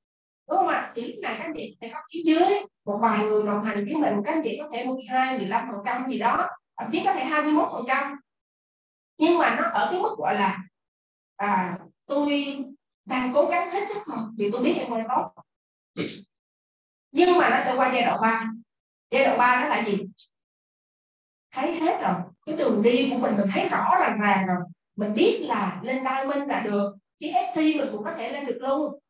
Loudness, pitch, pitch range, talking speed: -25 LUFS, 255 Hz, 215-305 Hz, 205 wpm